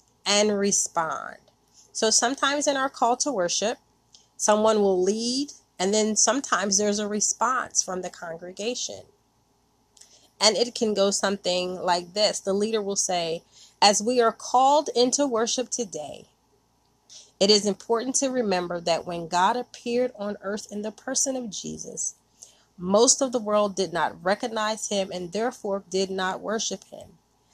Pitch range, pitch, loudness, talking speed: 190-240 Hz, 210 Hz, -24 LUFS, 150 wpm